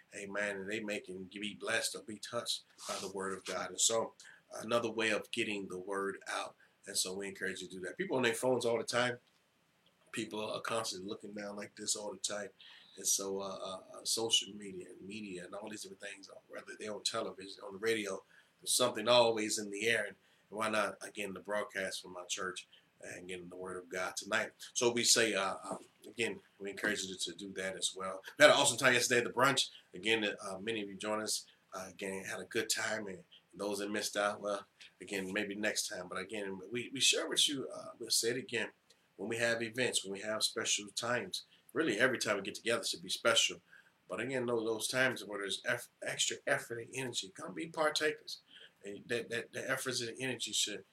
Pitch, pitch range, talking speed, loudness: 105 Hz, 95-115 Hz, 225 wpm, -35 LUFS